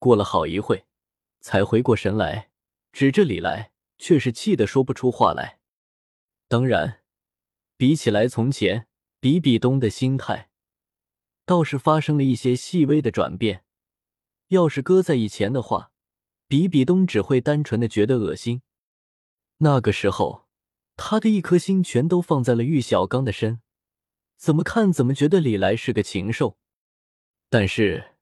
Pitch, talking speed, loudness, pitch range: 125 Hz, 215 characters per minute, -21 LUFS, 105-150 Hz